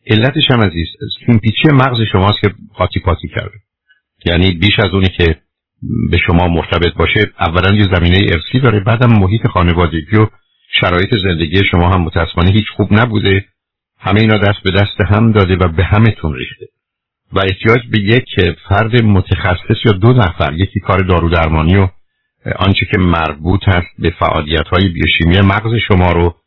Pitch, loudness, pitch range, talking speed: 95 Hz, -12 LUFS, 90-110 Hz, 165 wpm